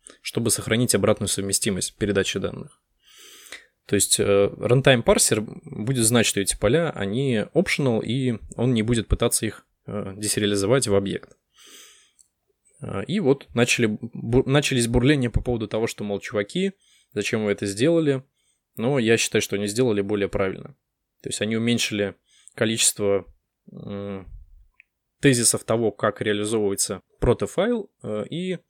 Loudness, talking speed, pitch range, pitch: -22 LUFS, 140 wpm, 100-125 Hz, 110 Hz